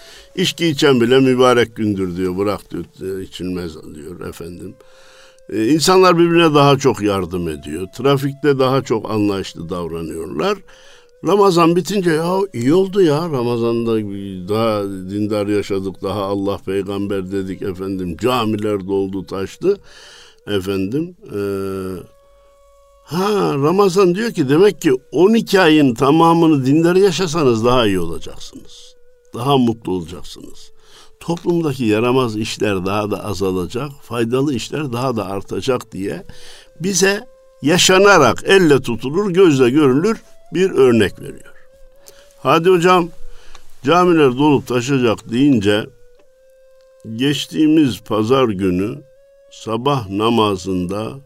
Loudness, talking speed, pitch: -16 LUFS, 110 wpm, 135 Hz